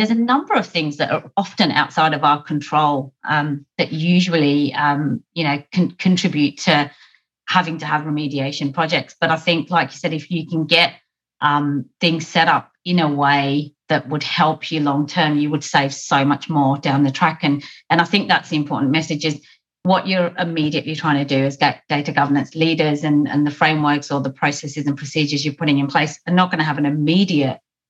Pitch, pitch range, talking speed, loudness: 150 Hz, 145-165 Hz, 210 wpm, -18 LUFS